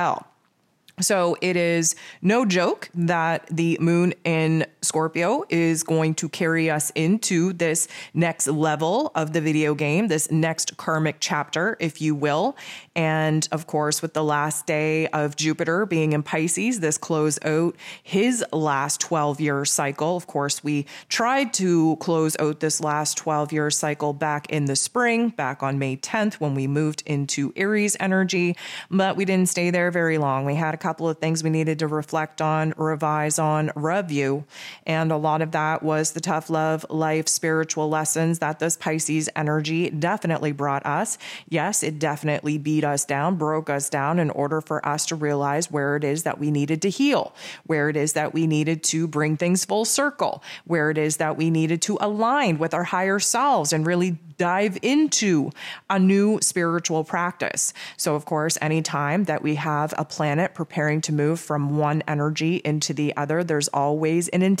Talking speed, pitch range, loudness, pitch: 175 wpm, 150-170 Hz, -23 LUFS, 160 Hz